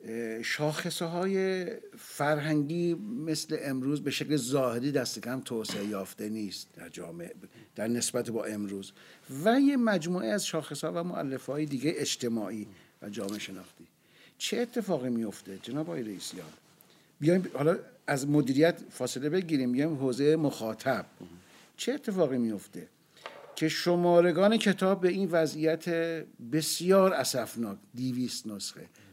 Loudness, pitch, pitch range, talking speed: -30 LUFS, 150 Hz, 115-170 Hz, 130 wpm